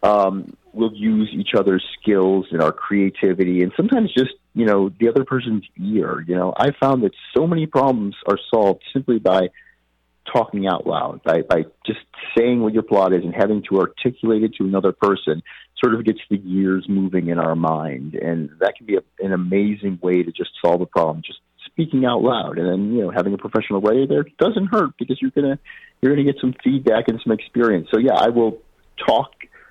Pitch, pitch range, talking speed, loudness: 105 Hz, 95-130 Hz, 210 wpm, -19 LUFS